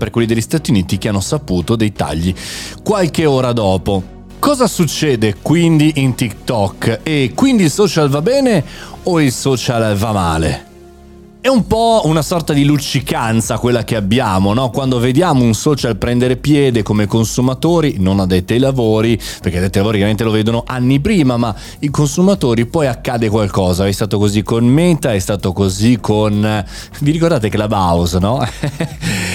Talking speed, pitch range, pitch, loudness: 170 wpm, 105-150 Hz, 120 Hz, -14 LUFS